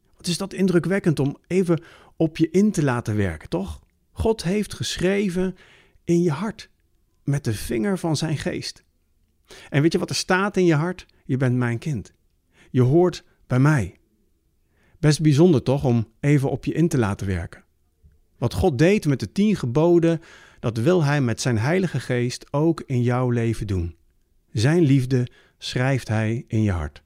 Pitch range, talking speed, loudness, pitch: 105-170 Hz, 175 wpm, -22 LUFS, 130 Hz